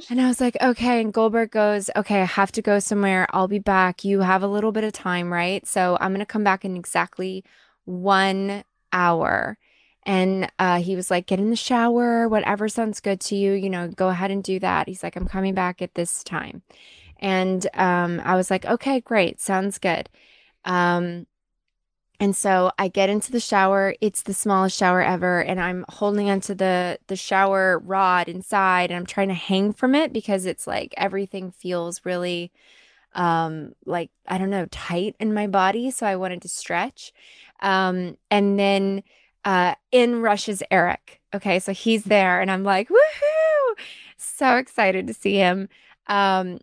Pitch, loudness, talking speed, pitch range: 195 Hz, -22 LUFS, 185 wpm, 185-210 Hz